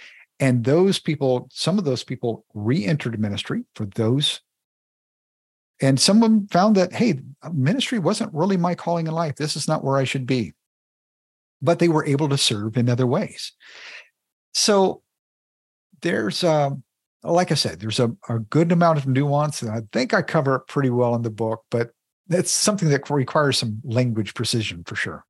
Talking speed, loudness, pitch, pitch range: 175 wpm, -21 LUFS, 140 Hz, 120-170 Hz